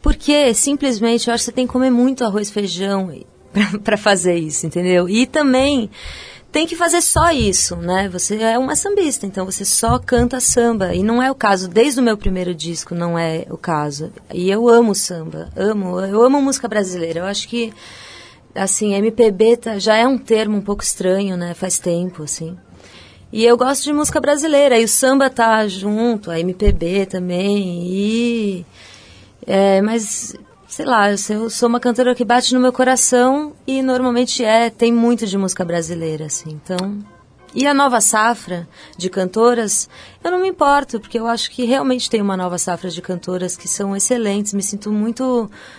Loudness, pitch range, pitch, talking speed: -16 LUFS, 185-245 Hz, 215 Hz, 180 wpm